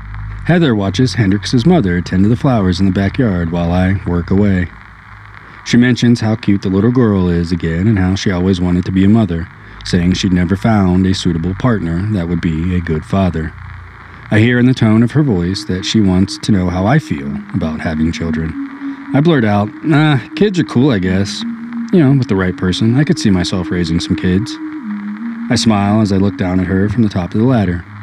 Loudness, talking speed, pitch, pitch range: -14 LUFS, 215 wpm, 100 Hz, 90-120 Hz